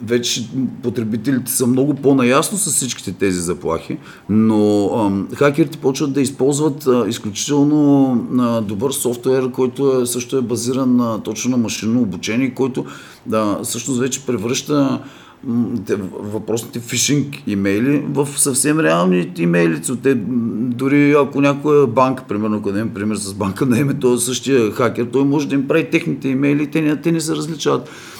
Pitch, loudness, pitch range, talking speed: 130 Hz, -17 LUFS, 115-140 Hz, 155 wpm